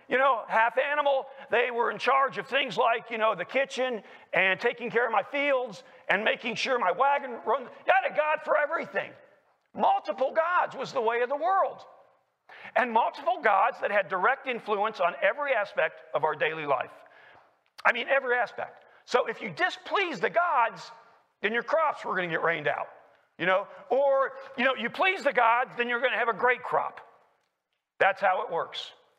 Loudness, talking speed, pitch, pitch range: -27 LUFS, 195 wpm, 255 Hz, 230-285 Hz